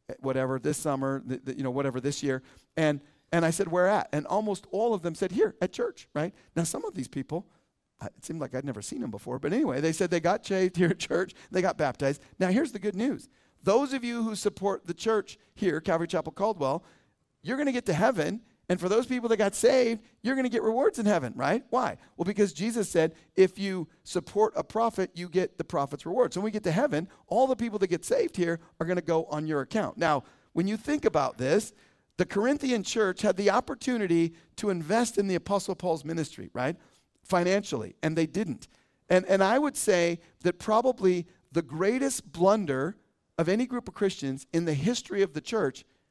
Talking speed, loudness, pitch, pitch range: 220 wpm, -29 LUFS, 185 Hz, 160-215 Hz